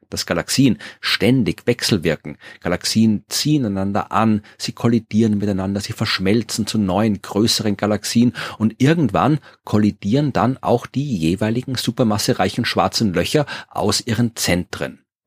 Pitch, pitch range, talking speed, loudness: 110 Hz, 100-120 Hz, 120 wpm, -19 LUFS